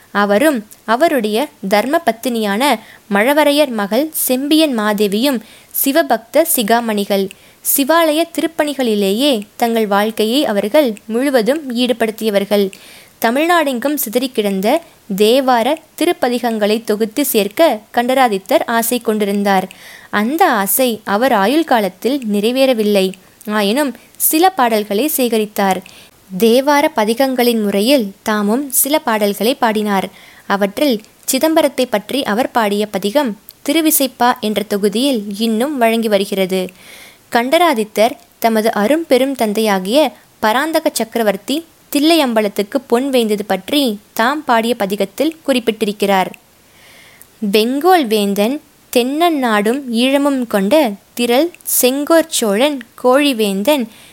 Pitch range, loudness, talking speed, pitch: 210-280 Hz, -15 LUFS, 90 wpm, 235 Hz